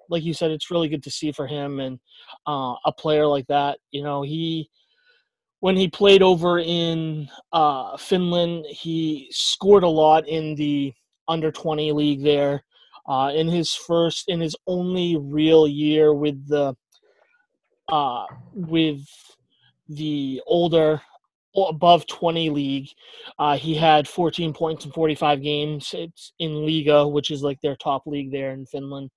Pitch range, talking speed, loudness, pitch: 145-170 Hz, 150 wpm, -21 LUFS, 155 Hz